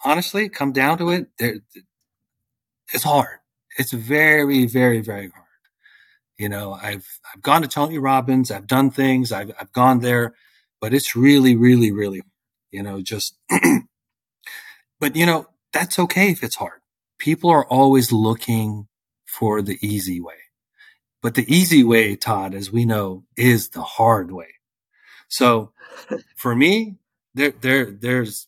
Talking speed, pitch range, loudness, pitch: 150 wpm, 105-135 Hz, -18 LUFS, 120 Hz